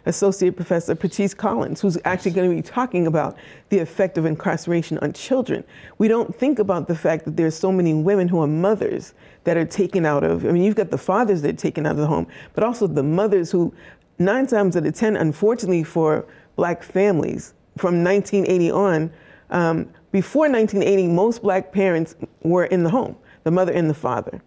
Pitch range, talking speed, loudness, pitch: 165-200 Hz, 200 wpm, -20 LUFS, 185 Hz